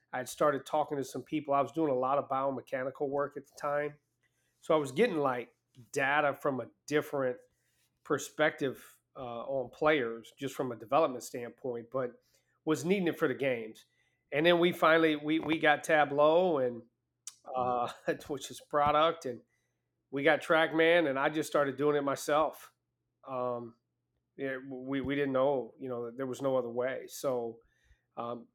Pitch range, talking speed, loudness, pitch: 125-150 Hz, 175 wpm, -31 LUFS, 140 Hz